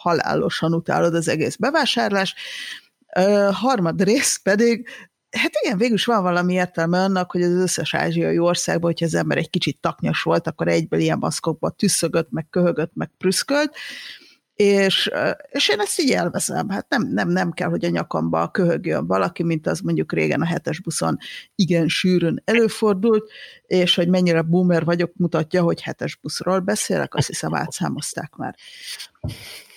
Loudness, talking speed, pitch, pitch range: -20 LUFS, 160 wpm, 180 Hz, 165-210 Hz